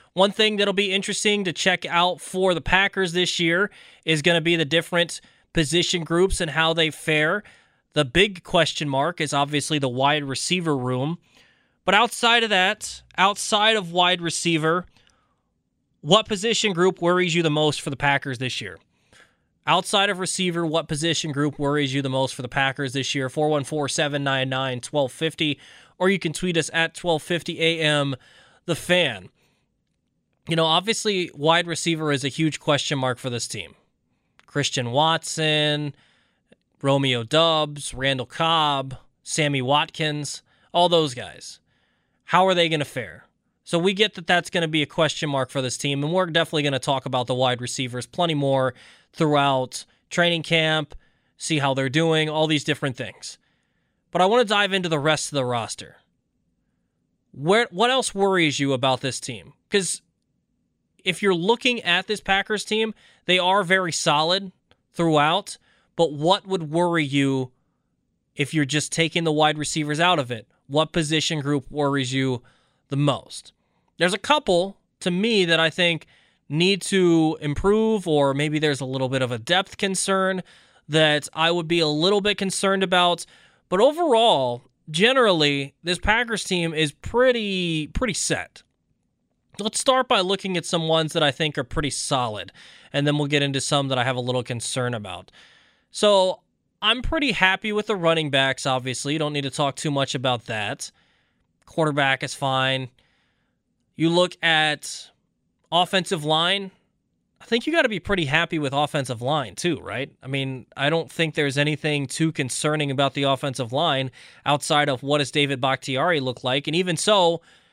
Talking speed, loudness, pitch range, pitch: 170 wpm, -22 LUFS, 140-180 Hz, 155 Hz